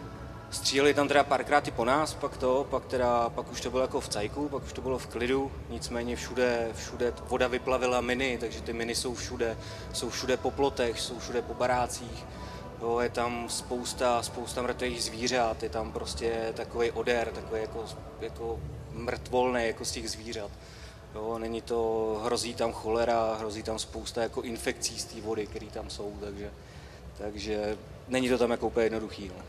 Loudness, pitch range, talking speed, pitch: -31 LUFS, 110-125 Hz, 180 wpm, 115 Hz